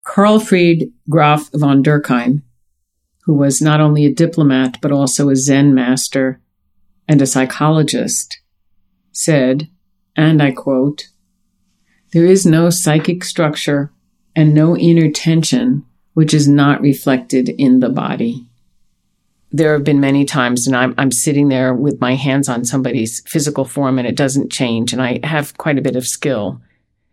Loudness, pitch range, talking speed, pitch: -14 LUFS, 130-155 Hz, 150 wpm, 140 Hz